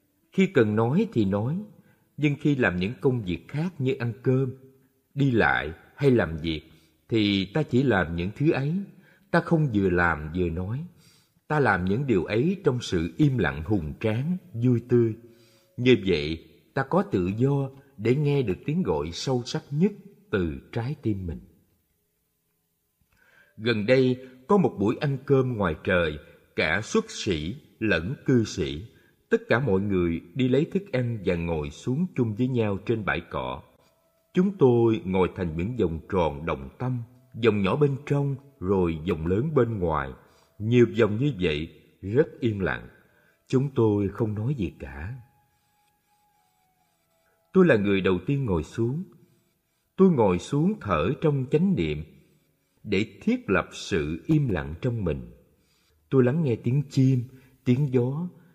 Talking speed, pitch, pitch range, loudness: 160 wpm, 125 Hz, 95-145 Hz, -25 LUFS